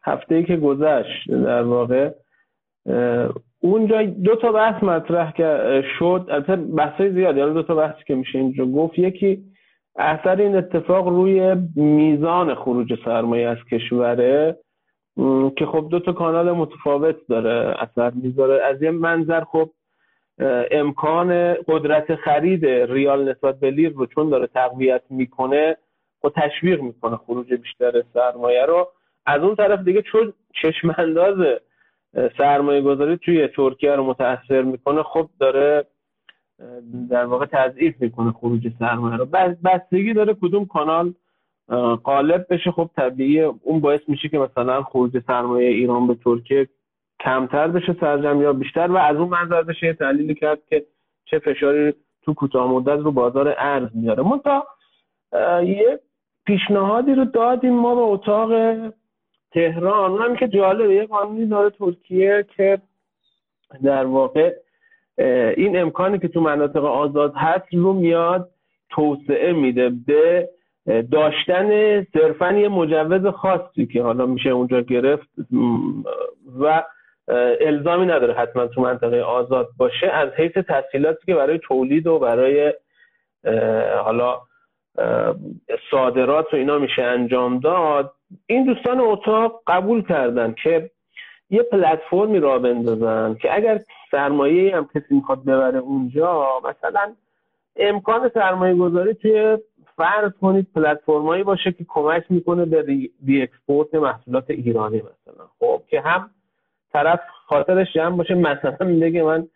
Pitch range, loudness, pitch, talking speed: 135-190 Hz, -19 LUFS, 160 Hz, 130 wpm